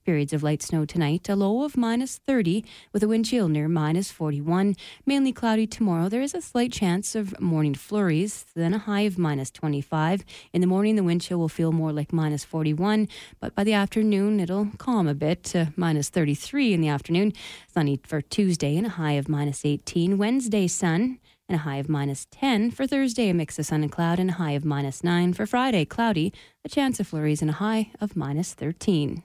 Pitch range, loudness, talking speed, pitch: 155-215 Hz, -25 LUFS, 215 wpm, 180 Hz